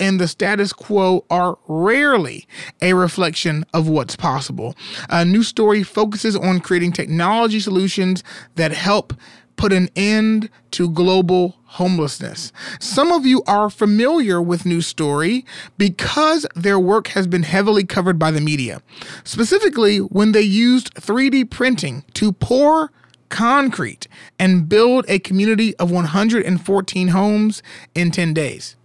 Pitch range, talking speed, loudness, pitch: 175-215 Hz, 135 wpm, -17 LUFS, 190 Hz